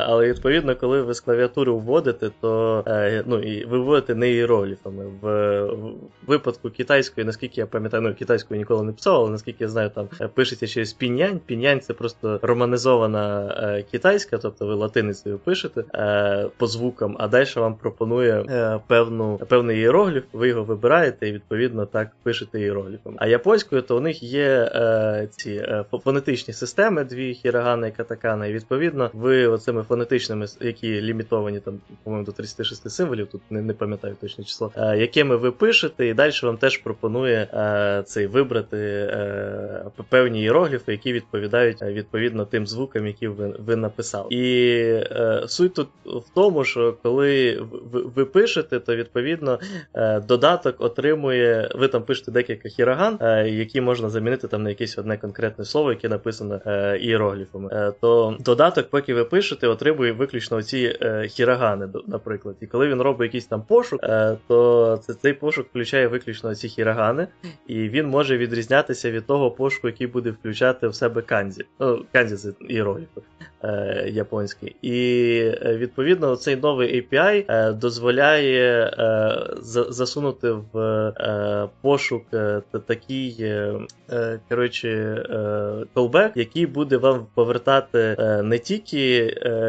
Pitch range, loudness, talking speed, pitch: 110-125 Hz, -22 LUFS, 150 wpm, 115 Hz